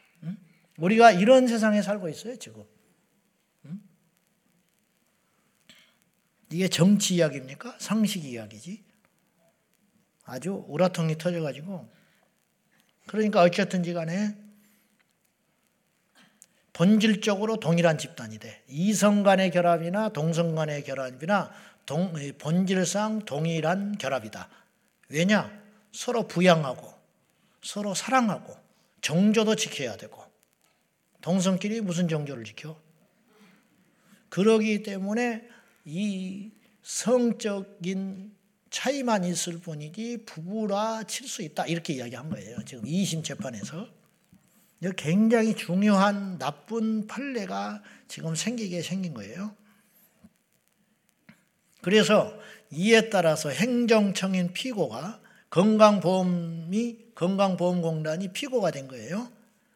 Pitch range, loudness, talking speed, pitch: 170-215 Hz, -26 LUFS, 225 characters per minute, 195 Hz